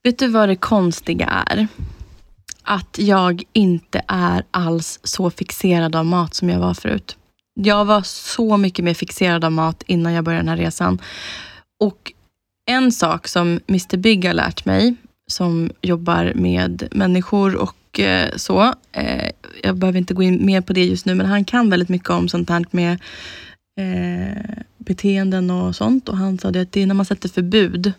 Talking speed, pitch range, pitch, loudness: 170 wpm, 170-200 Hz, 185 Hz, -18 LUFS